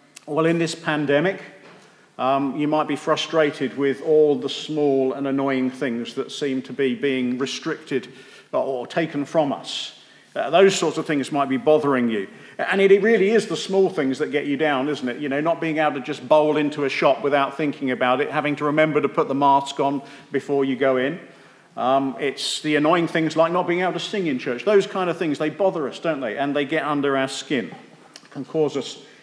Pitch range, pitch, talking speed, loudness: 135-160 Hz, 145 Hz, 220 wpm, -21 LUFS